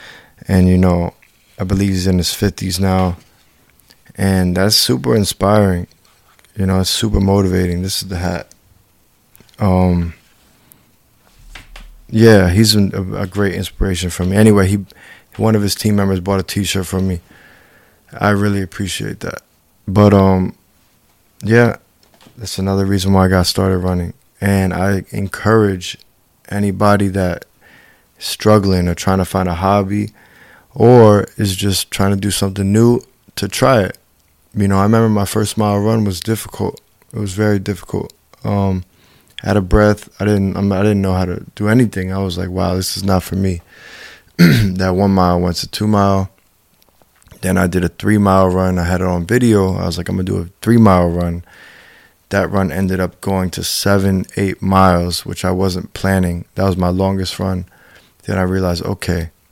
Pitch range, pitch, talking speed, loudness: 90-105 Hz, 95 Hz, 170 wpm, -15 LUFS